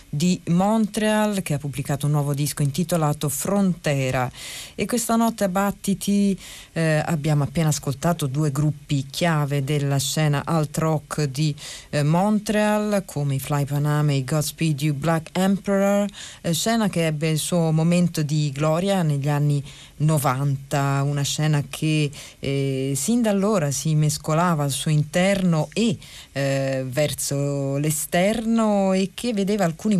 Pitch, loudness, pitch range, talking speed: 155 Hz, -22 LUFS, 145-190 Hz, 140 wpm